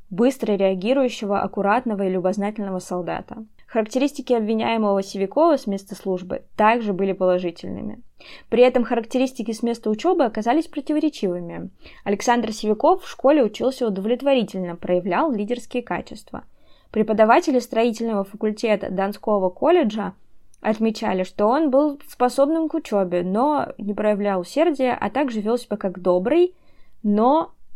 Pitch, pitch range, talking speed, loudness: 220 Hz, 200-260 Hz, 120 wpm, -21 LUFS